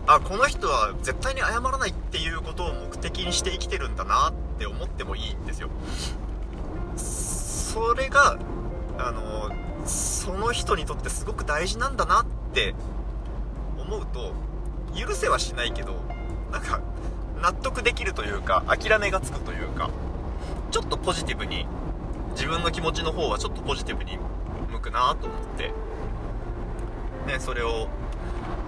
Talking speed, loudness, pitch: 290 characters per minute, -27 LUFS, 80 Hz